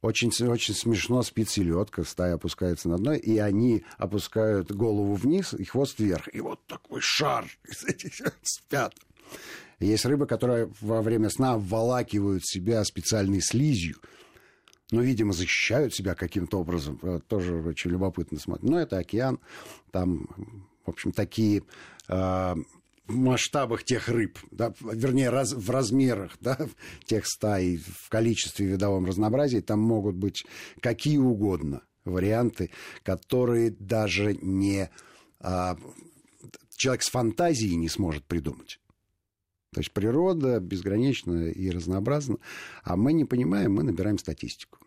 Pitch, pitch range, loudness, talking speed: 105 Hz, 90-115 Hz, -27 LUFS, 130 wpm